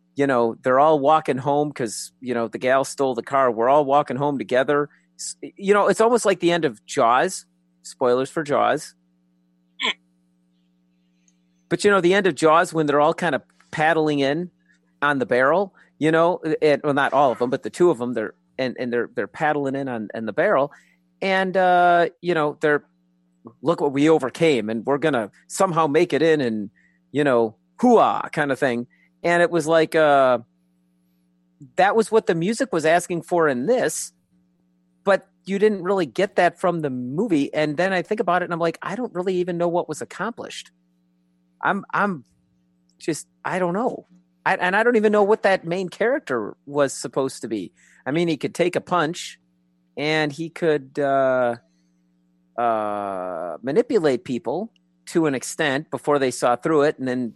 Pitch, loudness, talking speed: 145 Hz, -21 LUFS, 190 wpm